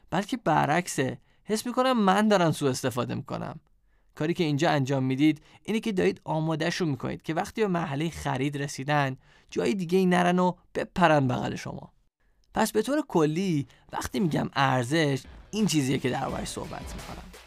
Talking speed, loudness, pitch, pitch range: 160 wpm, -27 LUFS, 160 Hz, 140-185 Hz